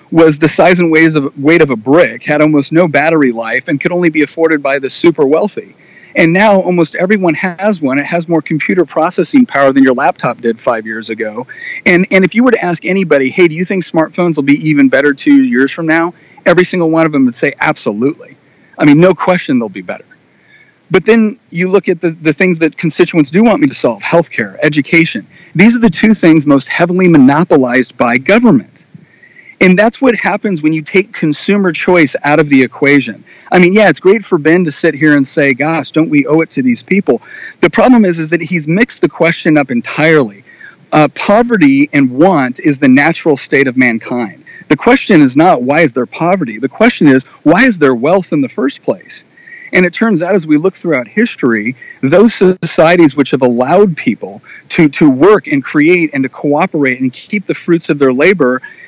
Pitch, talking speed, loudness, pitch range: 170 Hz, 210 wpm, -10 LUFS, 150-200 Hz